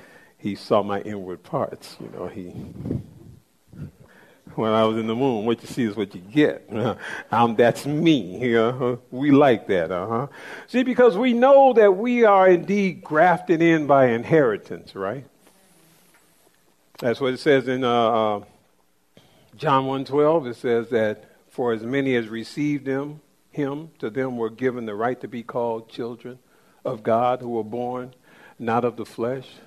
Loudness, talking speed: -21 LUFS, 165 wpm